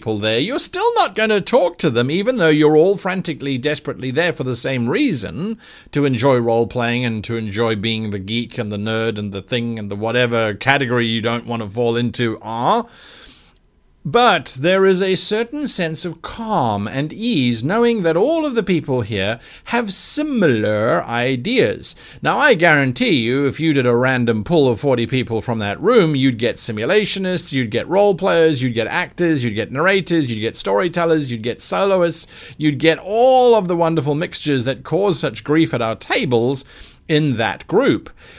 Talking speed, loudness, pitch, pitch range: 185 wpm, -17 LUFS, 135 Hz, 115-175 Hz